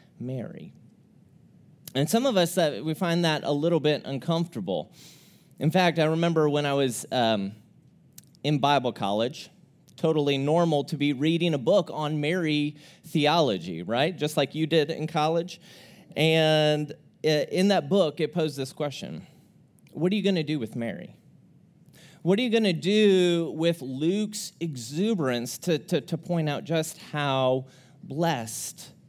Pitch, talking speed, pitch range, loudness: 155 Hz, 155 wpm, 145-170 Hz, -26 LUFS